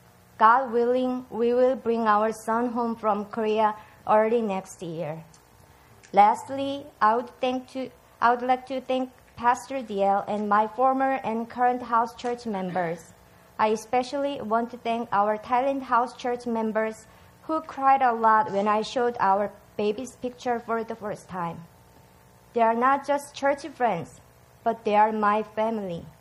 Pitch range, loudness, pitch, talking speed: 210-250 Hz, -25 LUFS, 230 Hz, 155 wpm